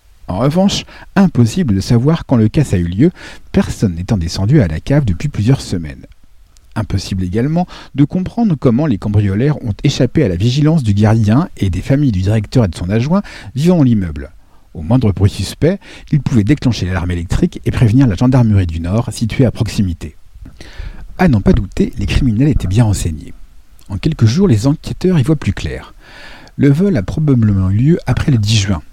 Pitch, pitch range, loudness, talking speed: 115 Hz, 95-140 Hz, -14 LUFS, 190 wpm